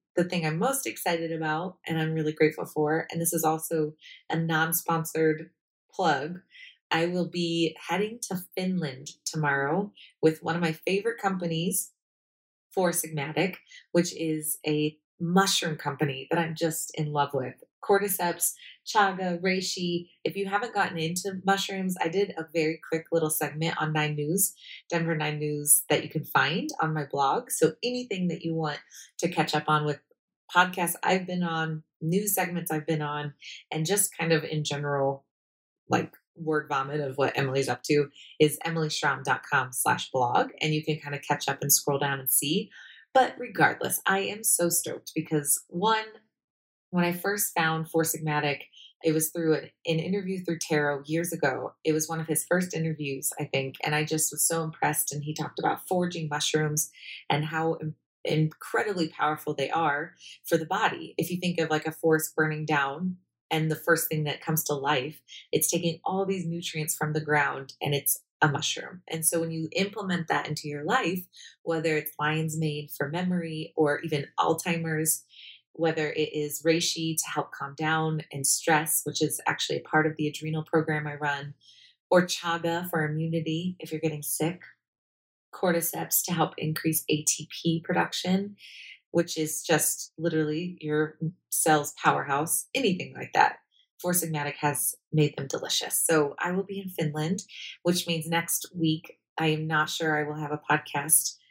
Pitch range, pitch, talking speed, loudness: 150-175 Hz, 160 Hz, 175 wpm, -27 LUFS